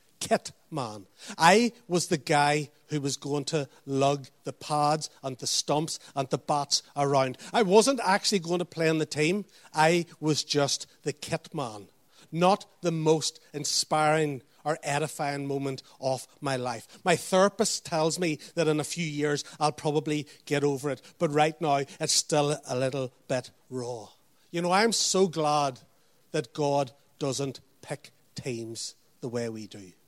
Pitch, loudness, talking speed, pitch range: 150 Hz, -28 LUFS, 165 wpm, 140-165 Hz